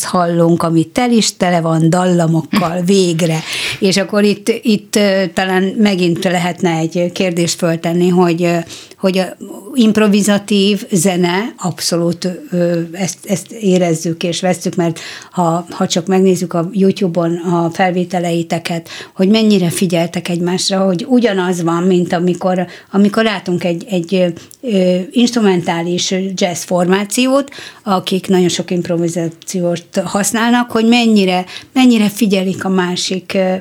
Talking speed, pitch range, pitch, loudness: 115 wpm, 175-195 Hz, 185 Hz, -14 LUFS